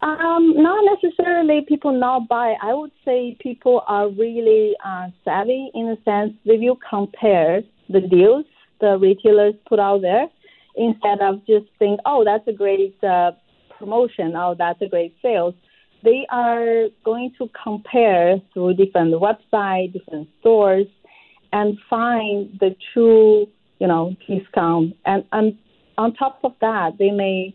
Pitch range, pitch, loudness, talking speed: 195-240 Hz, 215 Hz, -18 LUFS, 145 wpm